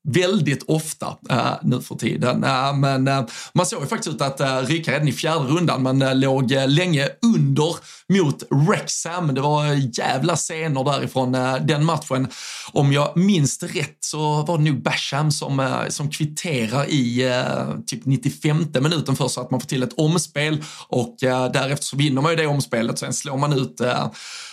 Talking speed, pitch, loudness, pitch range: 190 wpm, 145 Hz, -21 LUFS, 130-160 Hz